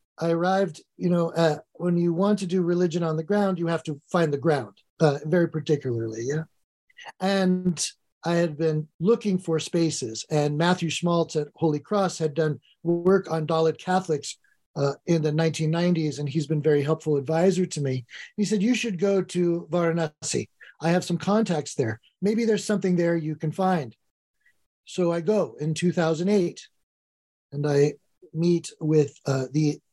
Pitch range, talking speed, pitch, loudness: 150-180 Hz, 170 wpm, 165 Hz, -25 LUFS